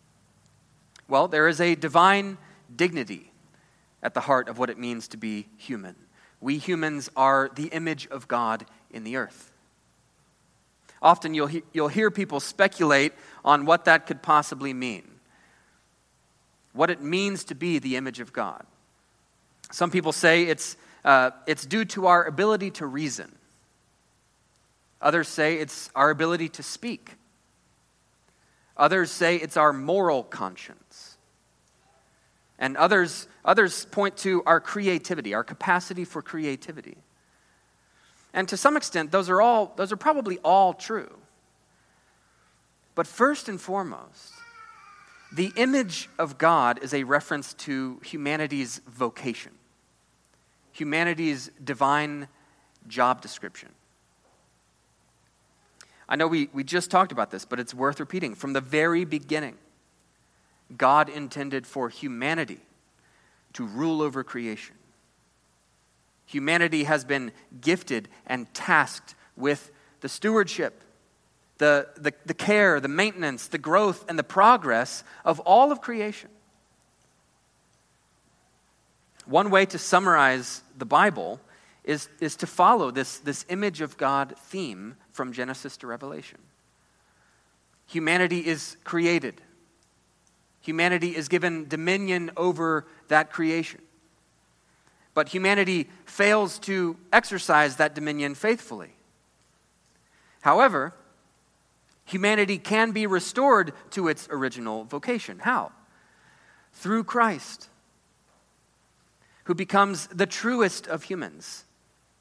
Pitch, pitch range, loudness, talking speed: 160 Hz, 140-185 Hz, -24 LUFS, 115 wpm